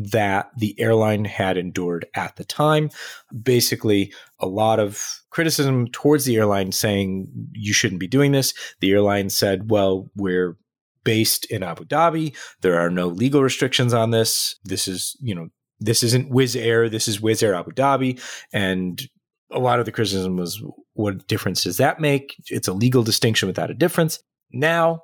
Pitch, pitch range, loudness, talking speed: 115 Hz, 95-130 Hz, -21 LUFS, 175 wpm